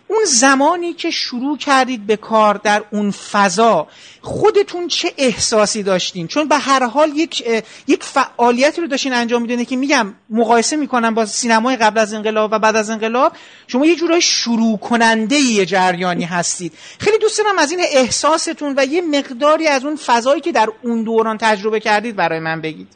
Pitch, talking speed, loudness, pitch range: 240 Hz, 175 wpm, -15 LUFS, 220-300 Hz